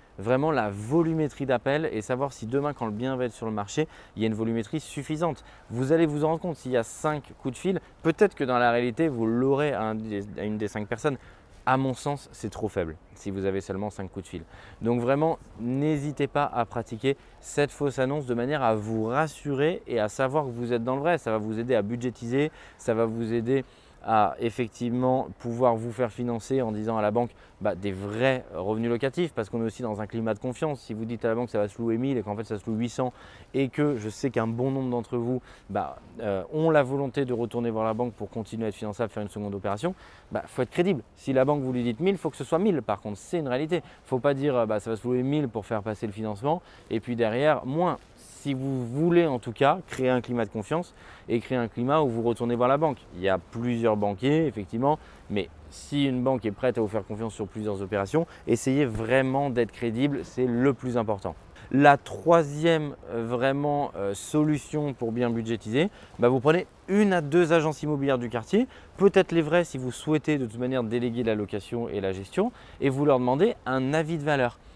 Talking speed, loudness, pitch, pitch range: 240 wpm, -27 LUFS, 125 Hz, 110-145 Hz